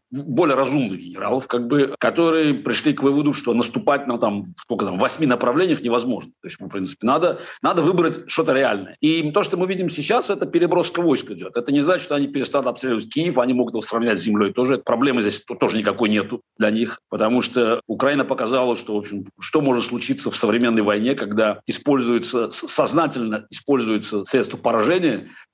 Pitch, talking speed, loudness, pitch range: 125 Hz, 180 wpm, -20 LUFS, 110-145 Hz